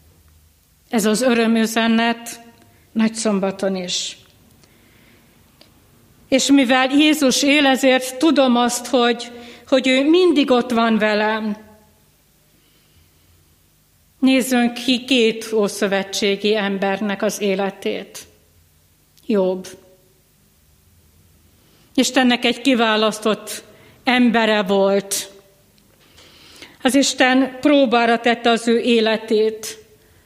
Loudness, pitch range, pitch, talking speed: -17 LUFS, 195-250 Hz, 225 Hz, 80 wpm